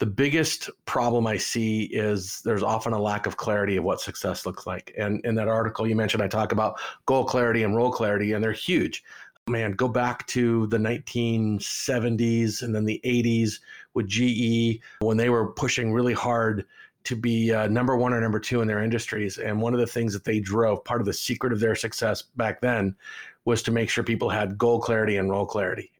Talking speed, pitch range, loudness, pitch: 210 wpm, 110-120 Hz, -25 LUFS, 115 Hz